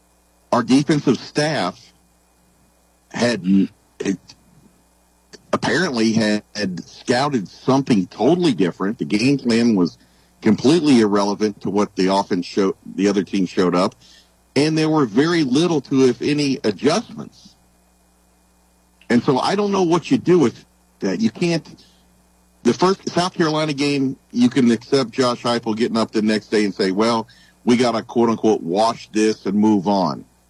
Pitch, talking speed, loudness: 110 Hz, 150 wpm, -19 LUFS